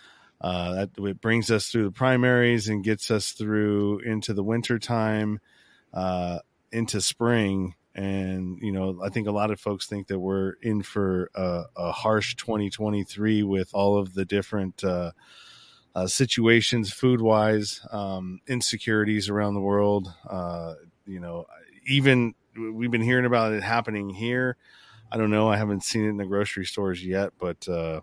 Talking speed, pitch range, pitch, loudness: 165 wpm, 95-110 Hz, 105 Hz, -26 LUFS